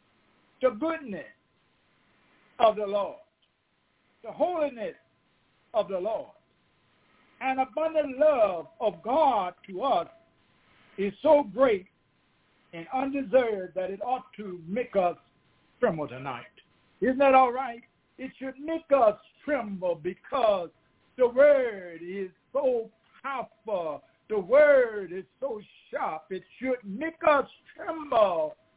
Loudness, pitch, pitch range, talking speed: -27 LUFS, 260 Hz, 205-300 Hz, 115 wpm